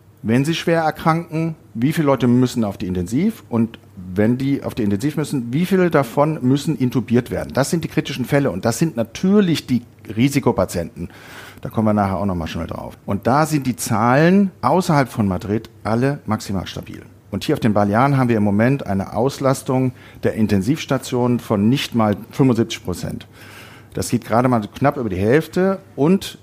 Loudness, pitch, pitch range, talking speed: -19 LUFS, 120 Hz, 110-145 Hz, 185 wpm